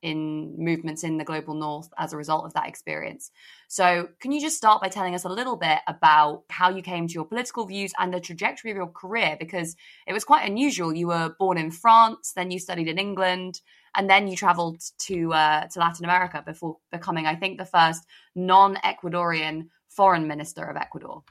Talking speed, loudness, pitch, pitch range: 205 wpm, -24 LUFS, 175 Hz, 160-195 Hz